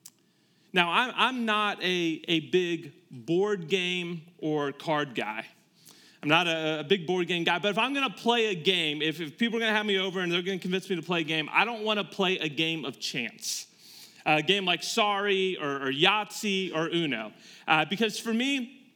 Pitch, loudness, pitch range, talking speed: 180 Hz, -27 LUFS, 160-205 Hz, 205 wpm